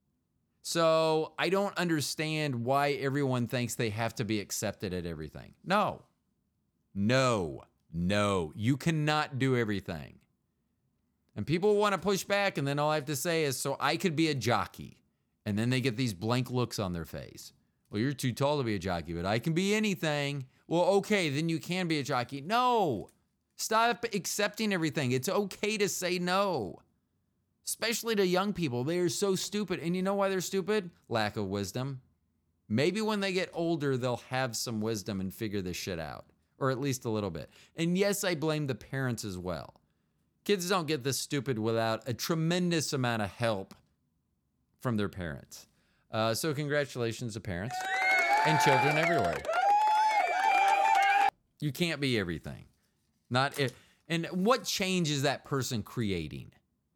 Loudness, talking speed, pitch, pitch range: -30 LUFS, 170 wpm, 140 Hz, 110-180 Hz